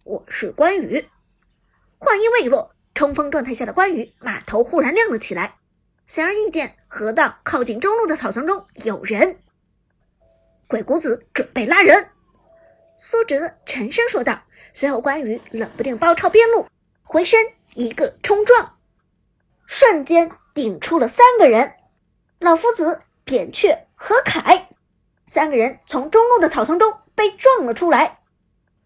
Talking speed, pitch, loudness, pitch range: 210 characters per minute, 335 Hz, -17 LUFS, 280-435 Hz